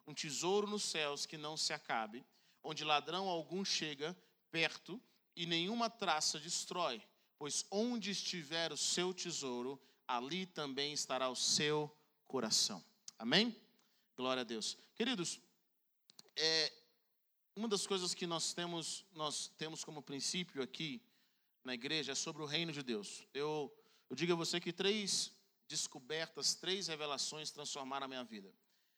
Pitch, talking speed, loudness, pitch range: 165 Hz, 140 wpm, -39 LUFS, 150-195 Hz